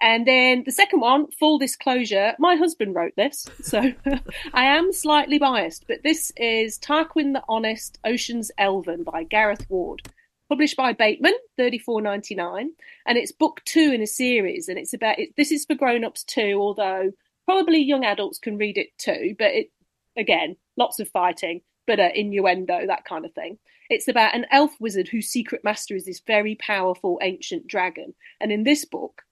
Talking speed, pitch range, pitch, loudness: 185 wpm, 210-305 Hz, 245 Hz, -22 LUFS